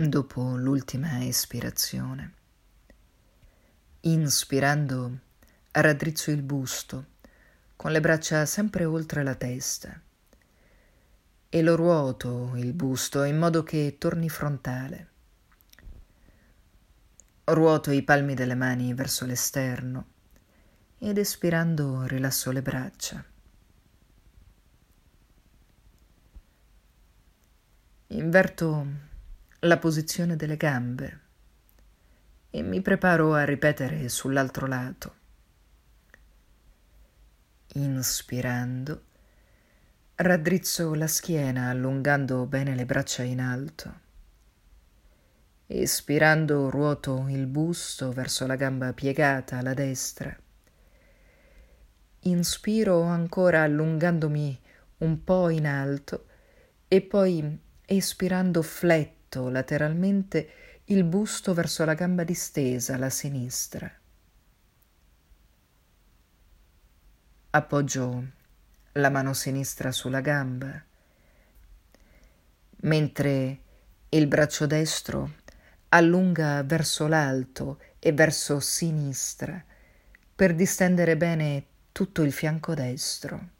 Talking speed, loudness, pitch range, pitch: 80 wpm, -26 LUFS, 125-160 Hz, 140 Hz